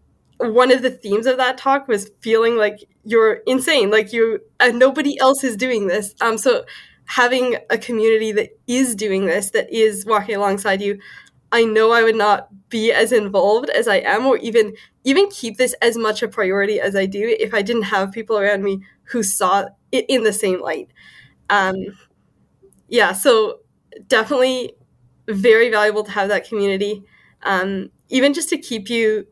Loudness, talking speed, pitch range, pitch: -17 LUFS, 180 wpm, 205-255 Hz, 225 Hz